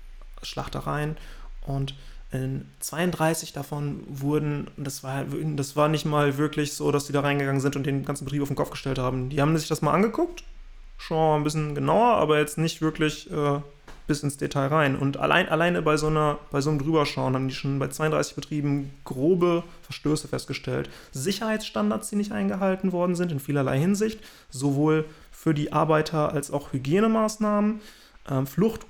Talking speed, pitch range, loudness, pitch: 175 wpm, 140-160 Hz, -26 LUFS, 150 Hz